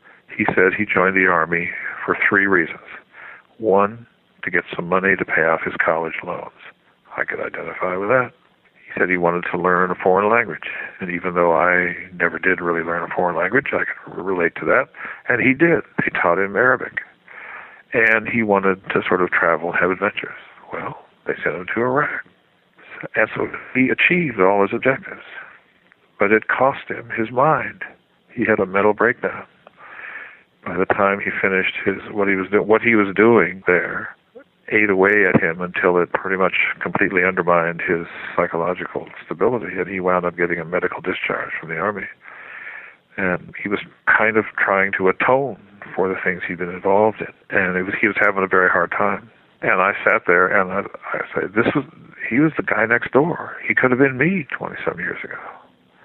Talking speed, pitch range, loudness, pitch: 190 wpm, 90-110 Hz, -19 LUFS, 95 Hz